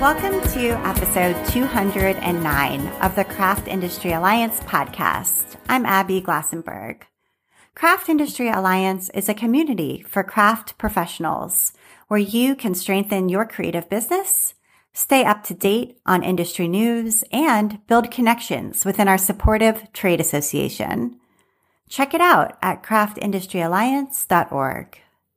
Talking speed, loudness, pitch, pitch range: 115 wpm, -20 LUFS, 210 Hz, 190-240 Hz